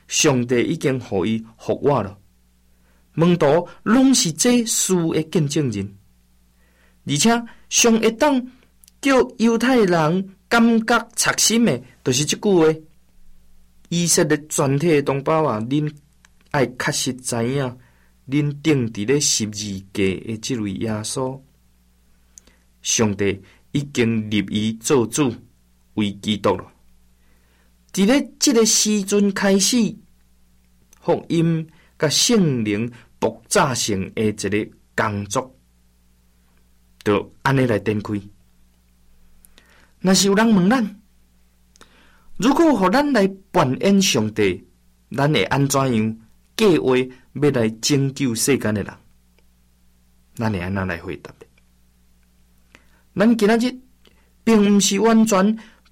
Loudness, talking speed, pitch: -19 LUFS, 160 characters per minute, 120 Hz